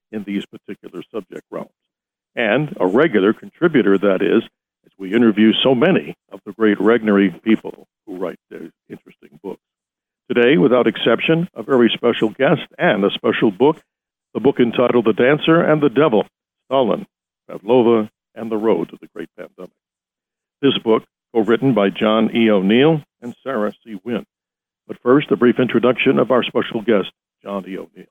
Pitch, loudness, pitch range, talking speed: 115 Hz, -16 LUFS, 105-125 Hz, 165 wpm